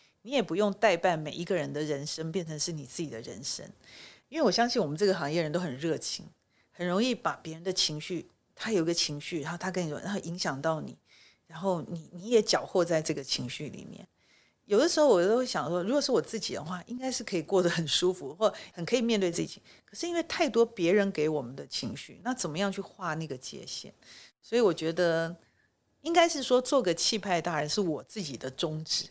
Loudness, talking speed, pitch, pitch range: -30 LUFS, 330 characters per minute, 180 Hz, 160-210 Hz